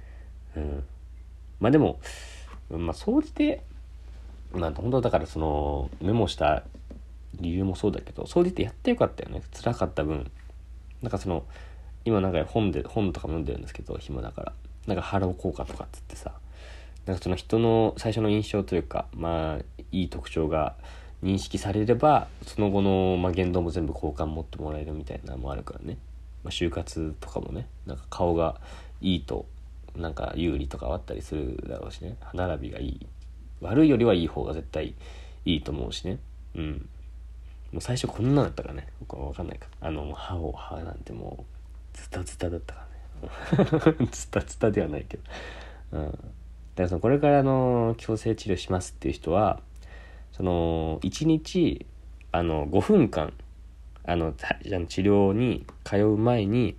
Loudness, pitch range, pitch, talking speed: -28 LUFS, 70-100 Hz, 80 Hz, 325 characters per minute